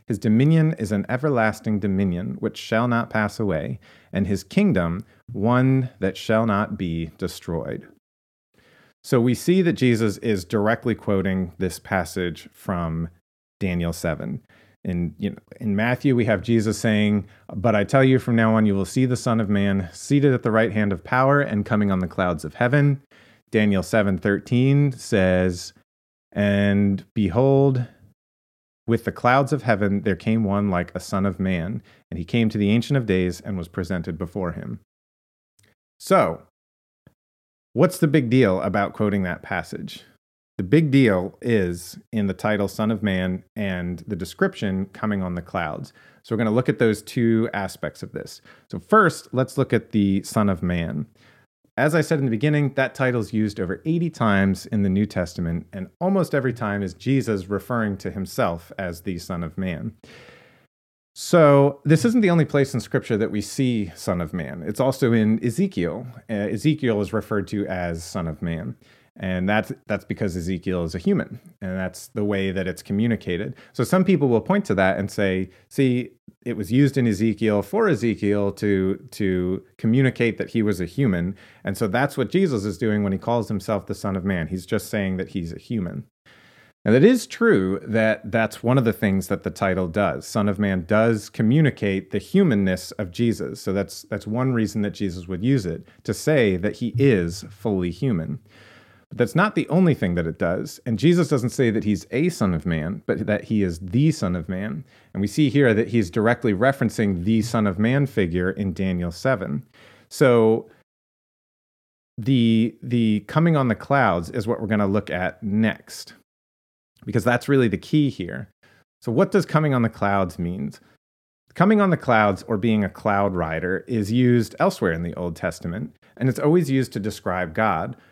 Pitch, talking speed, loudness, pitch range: 105 Hz, 190 wpm, -22 LUFS, 95-125 Hz